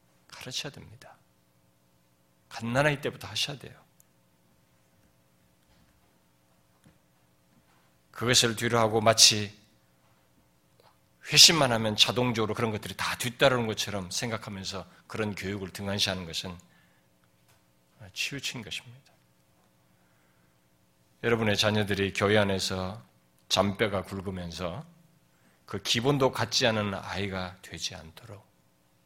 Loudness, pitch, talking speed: -26 LUFS, 90 Hz, 230 characters per minute